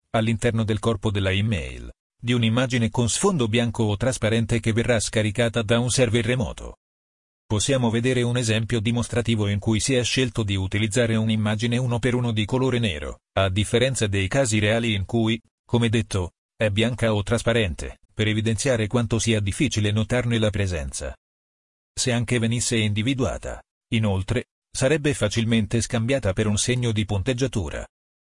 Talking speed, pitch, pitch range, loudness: 155 wpm, 115 Hz, 105-120 Hz, -23 LUFS